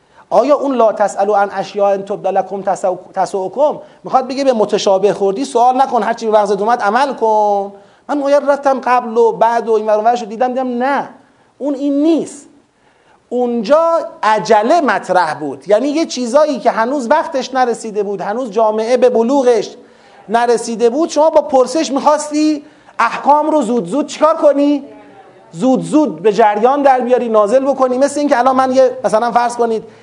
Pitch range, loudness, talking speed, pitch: 215-285 Hz, -14 LUFS, 165 wpm, 245 Hz